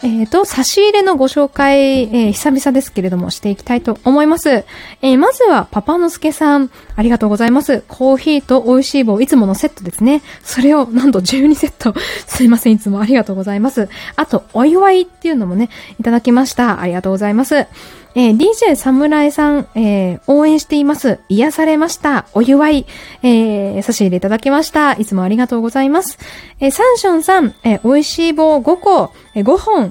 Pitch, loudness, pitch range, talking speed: 265 Hz, -12 LUFS, 225-300 Hz, 405 characters per minute